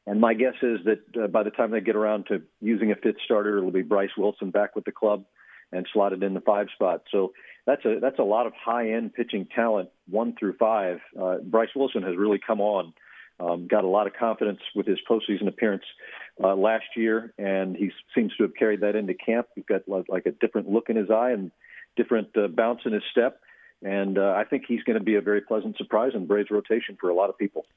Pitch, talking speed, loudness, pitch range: 105 Hz, 240 wpm, -25 LUFS, 100-115 Hz